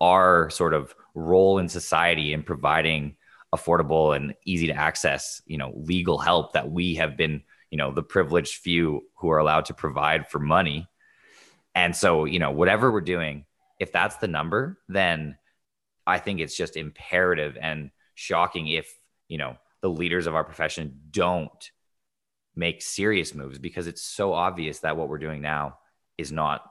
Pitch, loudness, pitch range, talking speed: 80 Hz, -25 LUFS, 75-90 Hz, 170 wpm